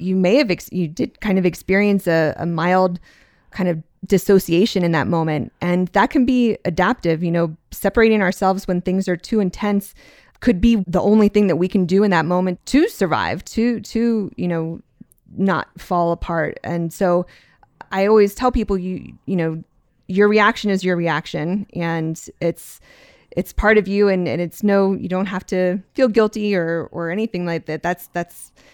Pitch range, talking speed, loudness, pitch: 170-205 Hz, 190 wpm, -19 LUFS, 185 Hz